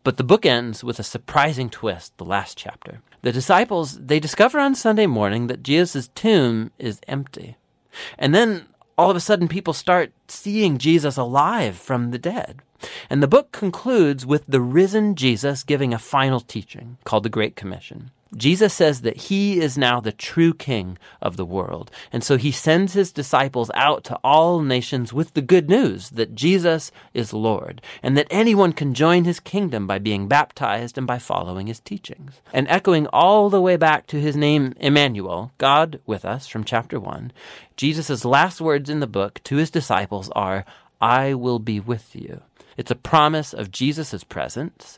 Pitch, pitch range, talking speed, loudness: 140 Hz, 120-165 Hz, 180 wpm, -20 LUFS